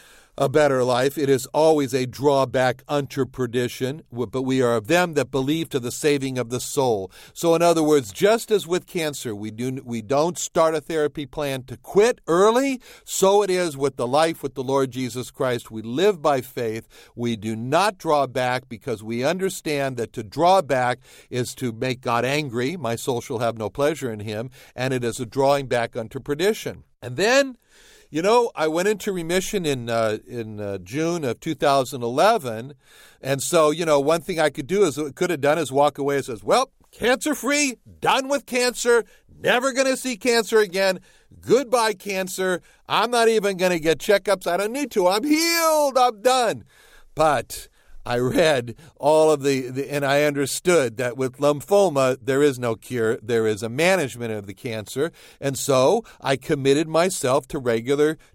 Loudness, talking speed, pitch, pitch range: -22 LUFS, 185 wpm, 145 Hz, 125-180 Hz